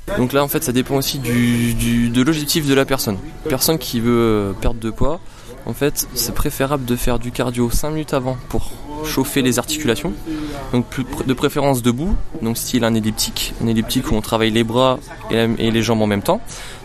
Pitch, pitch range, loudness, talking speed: 125 Hz, 115-140 Hz, -19 LUFS, 200 wpm